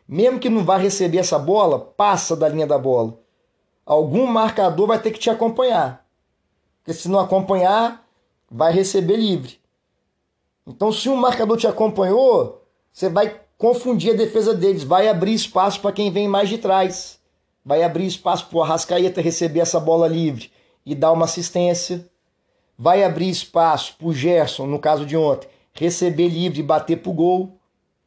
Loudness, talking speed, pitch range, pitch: -19 LUFS, 165 wpm, 165-215 Hz, 185 Hz